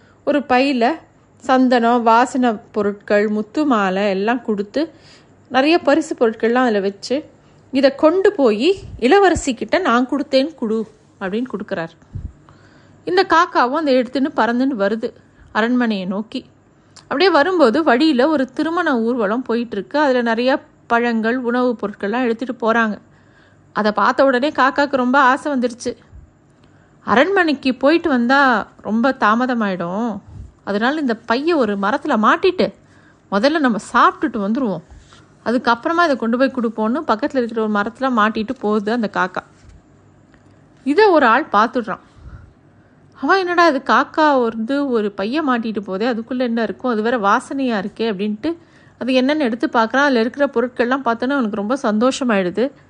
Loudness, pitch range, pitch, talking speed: -17 LUFS, 220-280 Hz, 250 Hz, 130 wpm